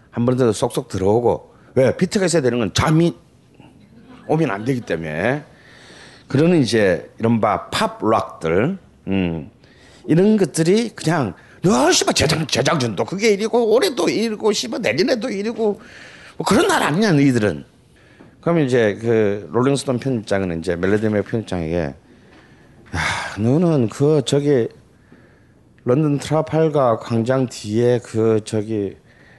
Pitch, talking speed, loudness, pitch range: 135 Hz, 270 characters per minute, -19 LUFS, 110-165 Hz